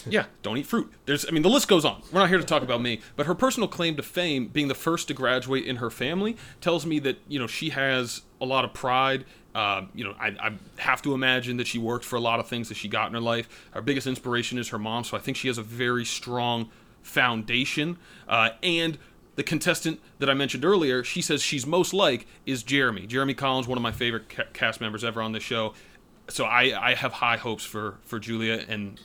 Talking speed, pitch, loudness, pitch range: 245 wpm, 130 Hz, -26 LUFS, 115-150 Hz